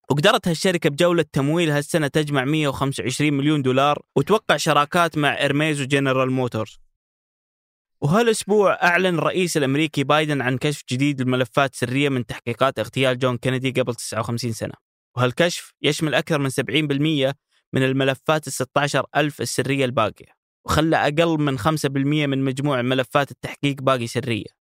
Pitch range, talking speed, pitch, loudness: 130-155 Hz, 135 wpm, 140 Hz, -21 LUFS